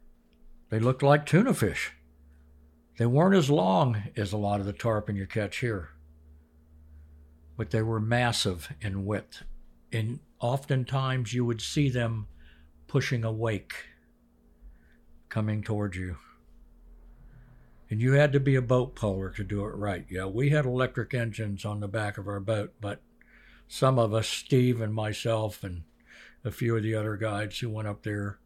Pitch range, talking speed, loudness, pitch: 90-120 Hz, 160 wpm, -28 LUFS, 105 Hz